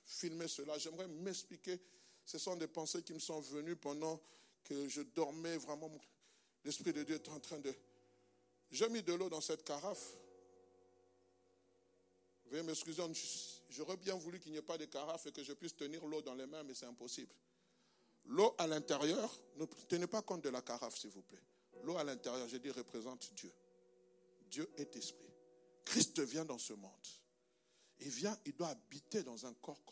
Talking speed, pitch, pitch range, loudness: 180 wpm, 145 Hz, 120-165 Hz, -44 LUFS